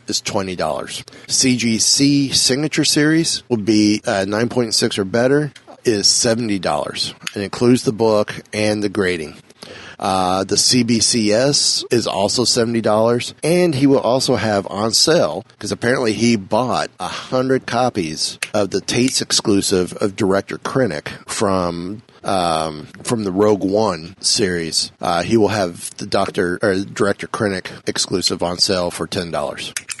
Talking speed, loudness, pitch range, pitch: 135 wpm, -17 LUFS, 100-125 Hz, 110 Hz